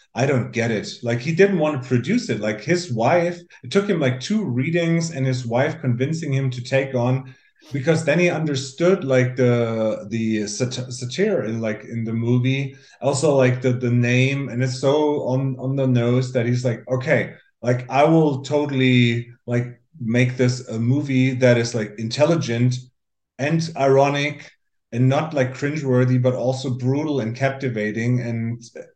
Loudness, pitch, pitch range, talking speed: -21 LUFS, 130 Hz, 120-145 Hz, 170 wpm